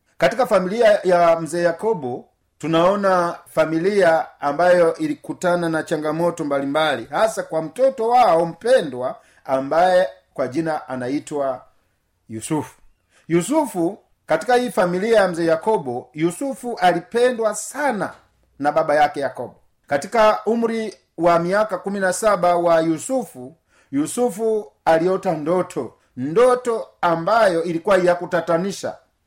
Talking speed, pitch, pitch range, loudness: 105 wpm, 175 Hz, 160-215 Hz, -19 LUFS